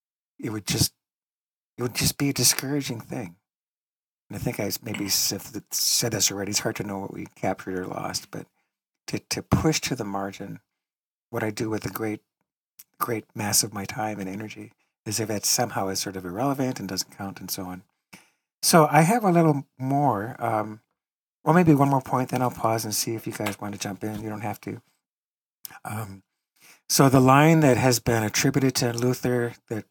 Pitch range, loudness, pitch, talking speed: 100-130 Hz, -24 LUFS, 115 Hz, 200 wpm